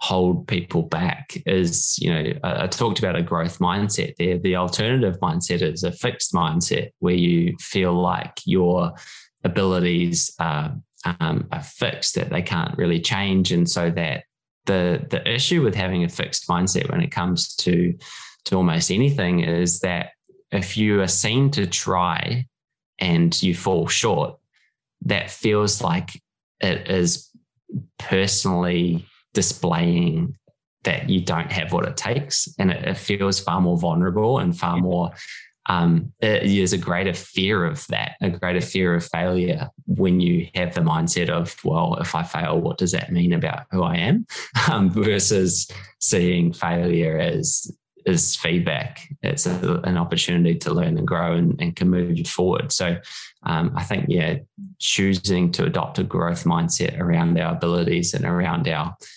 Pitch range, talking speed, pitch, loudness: 85-100 Hz, 160 wpm, 90 Hz, -21 LUFS